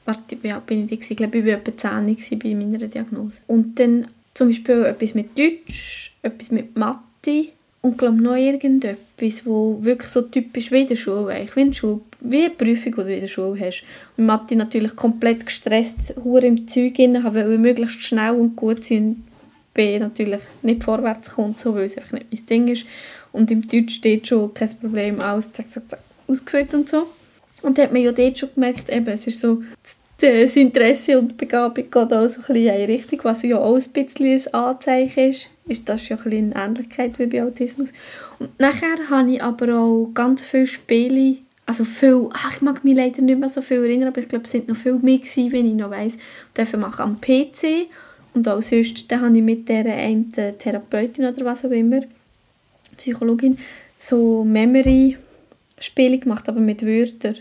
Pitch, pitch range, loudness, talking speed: 240 Hz, 225-260 Hz, -19 LUFS, 205 wpm